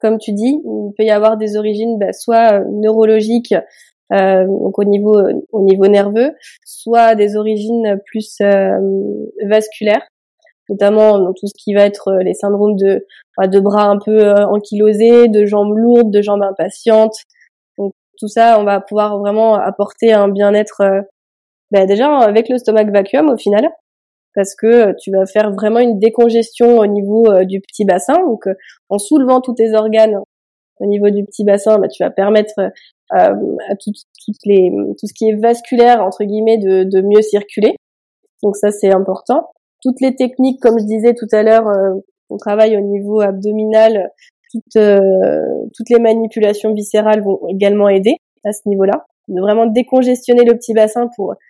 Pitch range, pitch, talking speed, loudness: 200-230 Hz, 215 Hz, 175 wpm, -12 LUFS